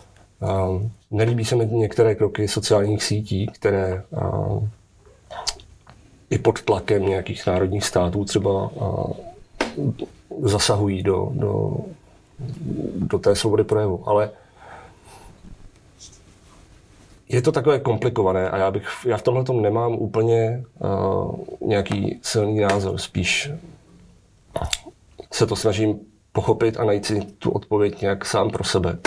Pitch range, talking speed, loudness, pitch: 100-115 Hz, 120 wpm, -22 LUFS, 105 Hz